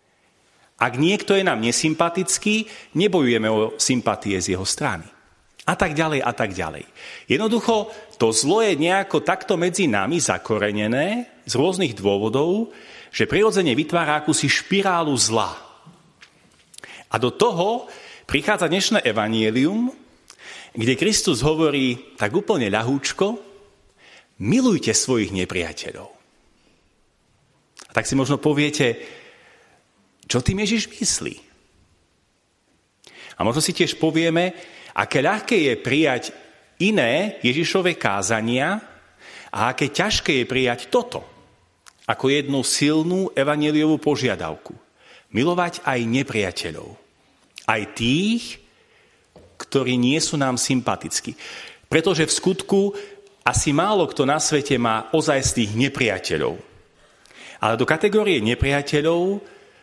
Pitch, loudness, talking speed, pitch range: 150 Hz, -21 LUFS, 105 wpm, 120-195 Hz